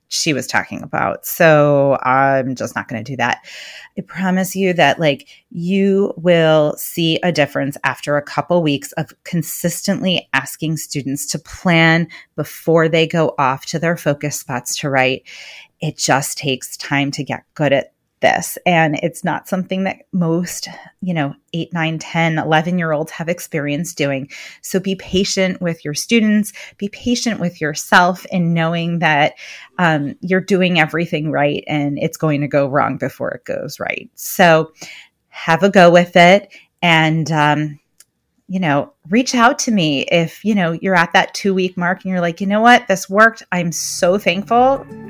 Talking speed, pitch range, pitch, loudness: 175 wpm, 150-185 Hz, 165 Hz, -16 LUFS